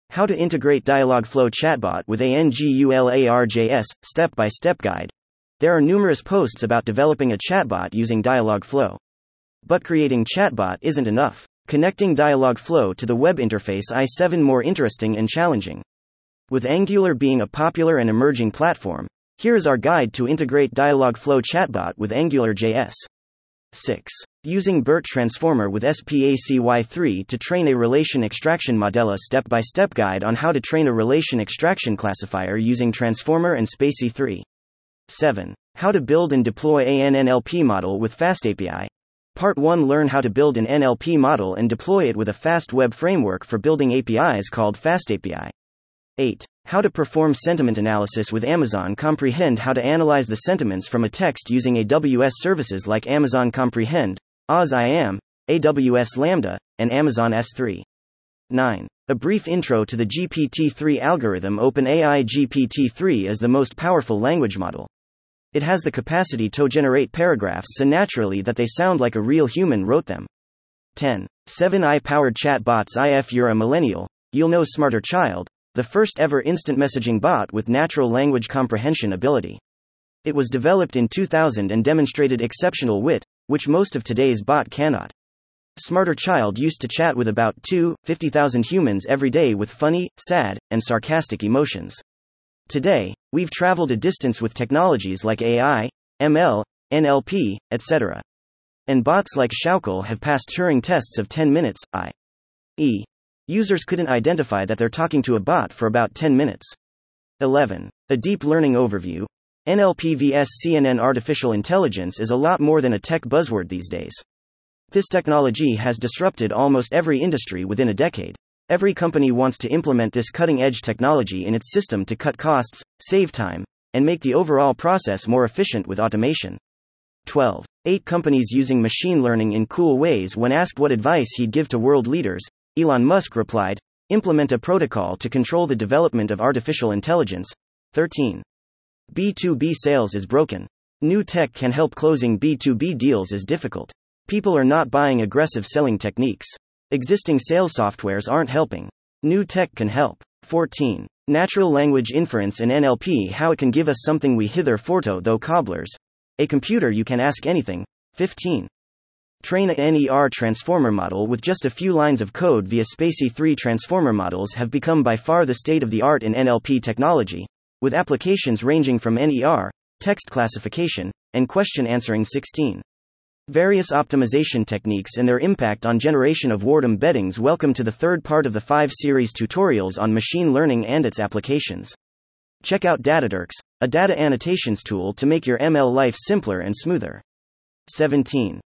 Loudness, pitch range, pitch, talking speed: -20 LUFS, 110-155 Hz, 130 Hz, 155 wpm